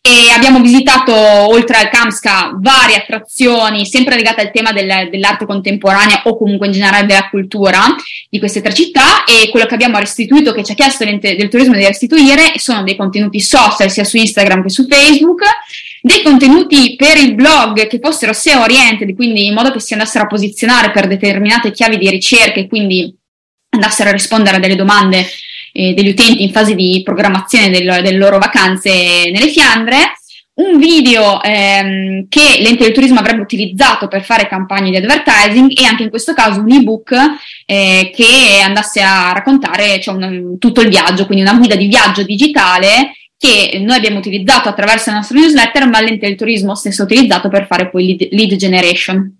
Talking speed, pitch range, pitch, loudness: 180 wpm, 200-250 Hz, 215 Hz, -8 LUFS